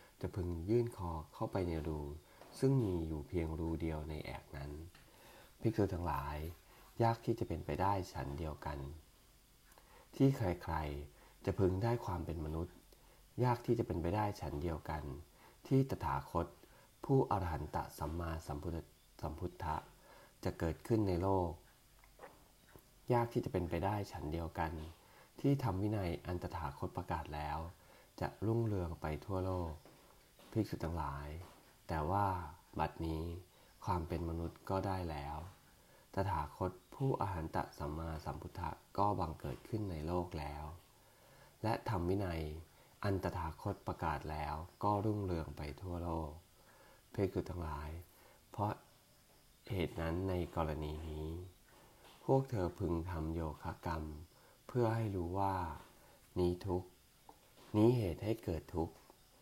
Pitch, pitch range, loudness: 85 Hz, 80-100 Hz, -40 LUFS